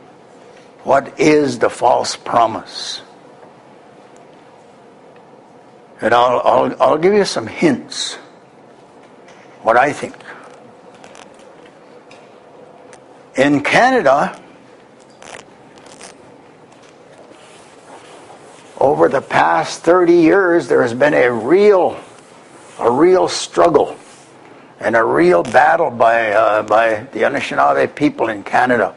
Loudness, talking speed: -14 LUFS, 90 wpm